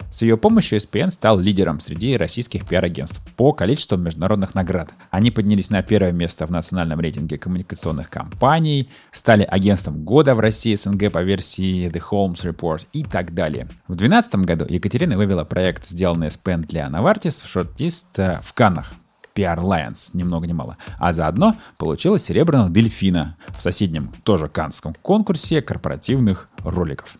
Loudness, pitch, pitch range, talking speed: -19 LUFS, 95 Hz, 85-110 Hz, 150 wpm